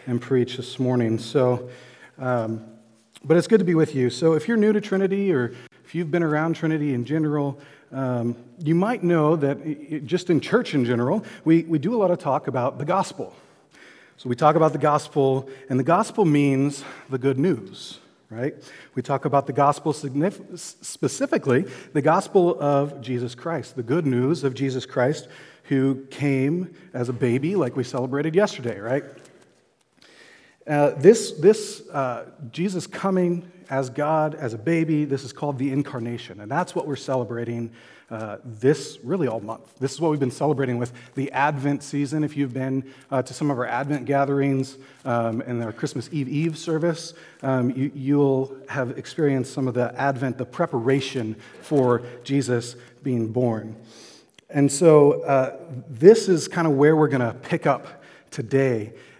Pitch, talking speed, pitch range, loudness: 140 Hz, 175 wpm, 125-155 Hz, -23 LUFS